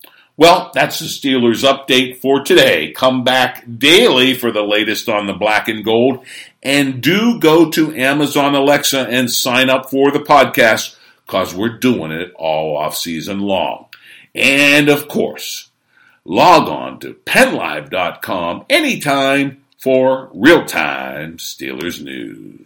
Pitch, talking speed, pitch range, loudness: 130 Hz, 135 wpm, 120-145 Hz, -13 LUFS